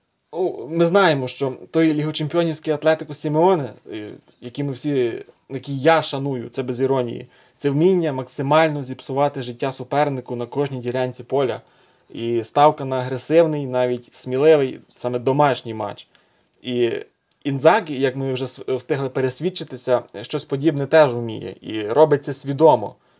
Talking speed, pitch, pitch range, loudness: 120 wpm, 140 Hz, 130-155 Hz, -20 LUFS